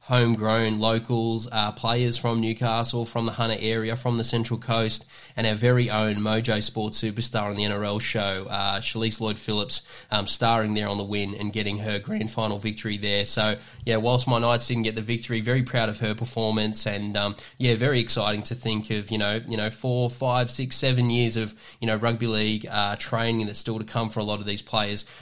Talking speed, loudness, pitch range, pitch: 215 wpm, -25 LUFS, 105-115 Hz, 110 Hz